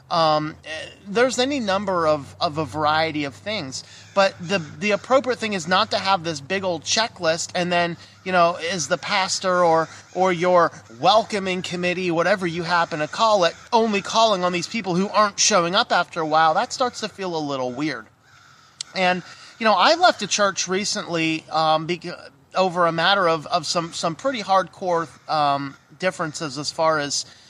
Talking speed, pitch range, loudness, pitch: 180 wpm, 160-195 Hz, -21 LUFS, 175 Hz